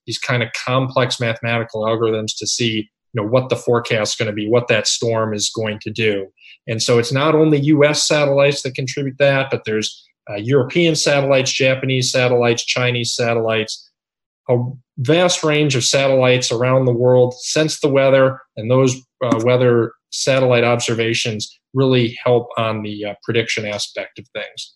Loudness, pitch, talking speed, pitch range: -17 LUFS, 125 Hz, 165 wpm, 115-135 Hz